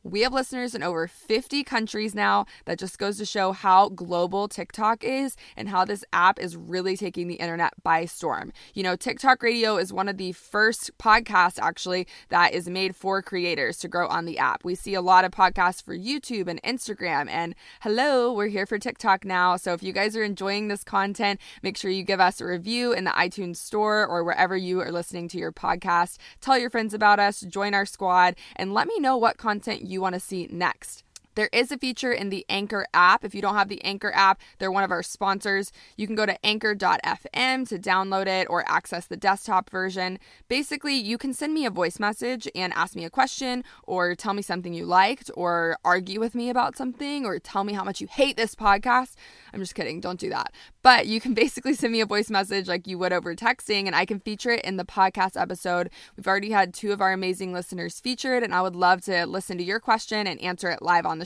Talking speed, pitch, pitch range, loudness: 230 wpm, 195 Hz, 180-220 Hz, -24 LUFS